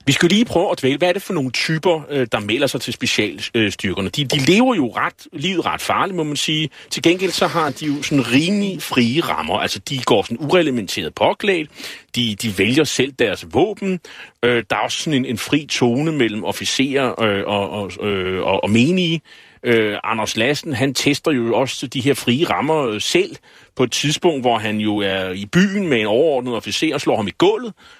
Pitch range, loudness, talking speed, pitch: 115-170 Hz, -18 LUFS, 205 wpm, 140 Hz